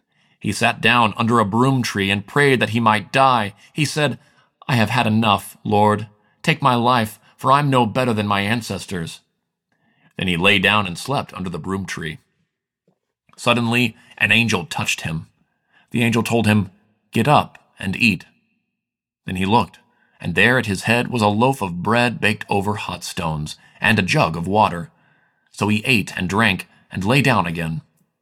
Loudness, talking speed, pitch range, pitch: -18 LUFS, 180 wpm, 100-120 Hz, 110 Hz